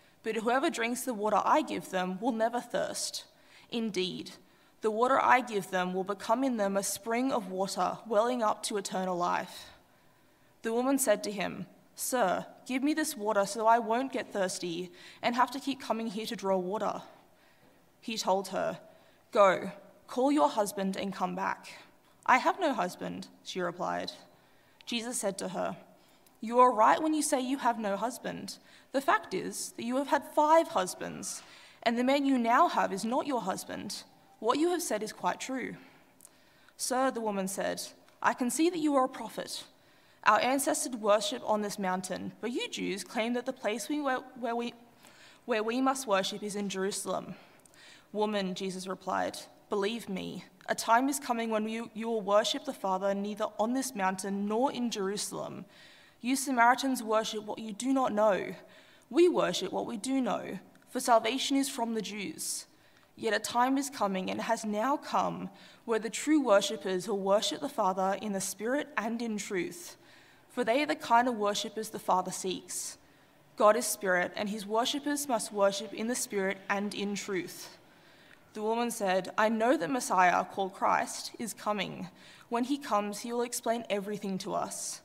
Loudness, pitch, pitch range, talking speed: -31 LUFS, 225 Hz, 200-260 Hz, 180 wpm